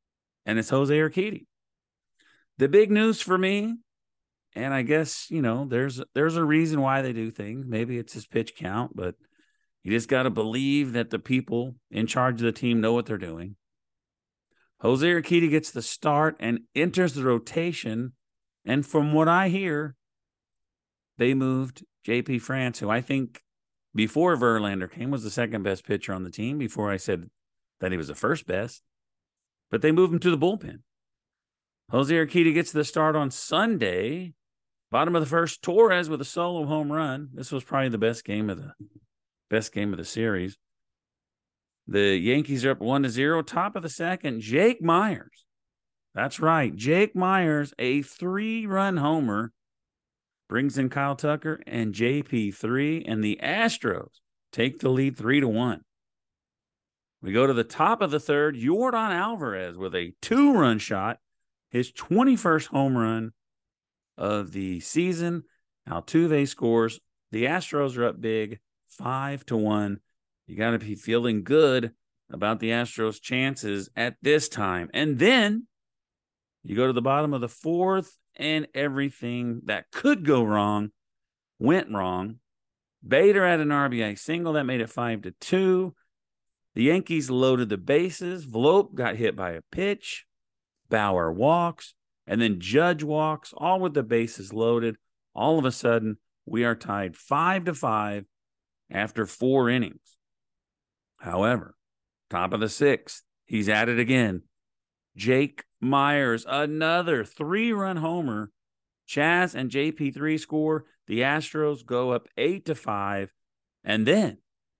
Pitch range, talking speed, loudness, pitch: 110-155 Hz, 155 wpm, -25 LUFS, 130 Hz